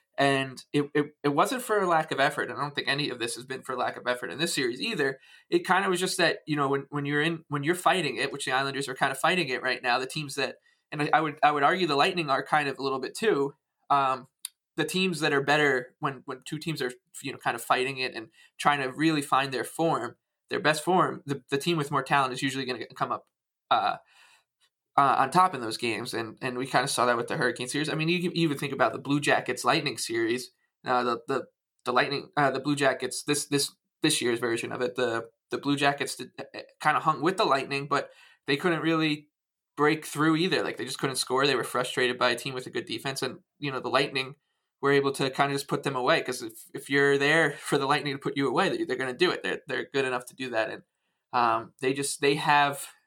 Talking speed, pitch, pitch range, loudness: 265 wpm, 145 Hz, 130-160 Hz, -27 LUFS